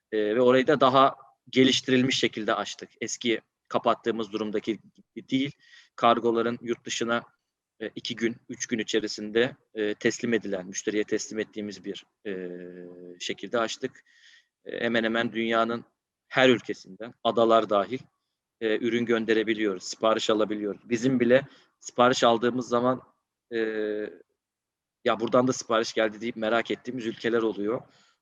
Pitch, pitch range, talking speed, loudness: 115 Hz, 110-120 Hz, 130 wpm, -26 LUFS